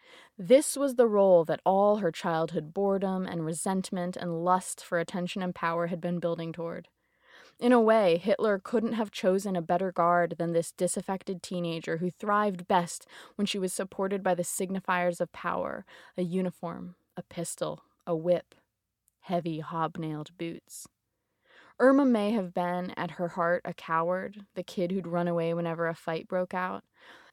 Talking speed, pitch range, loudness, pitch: 165 wpm, 170-195 Hz, -29 LUFS, 180 Hz